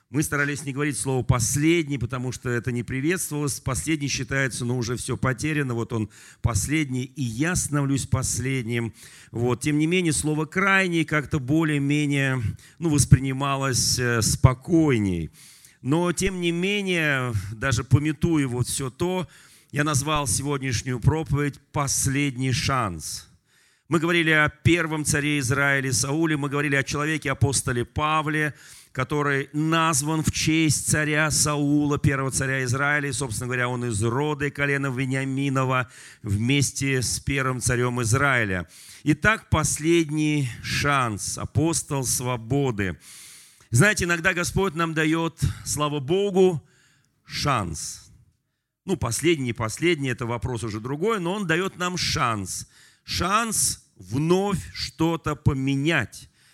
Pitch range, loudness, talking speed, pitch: 125-155 Hz, -23 LUFS, 120 wpm, 140 Hz